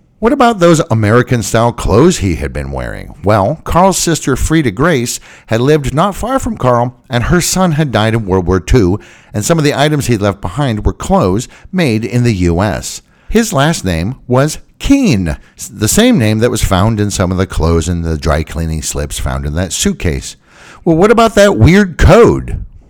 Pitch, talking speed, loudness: 120 Hz, 195 wpm, -12 LUFS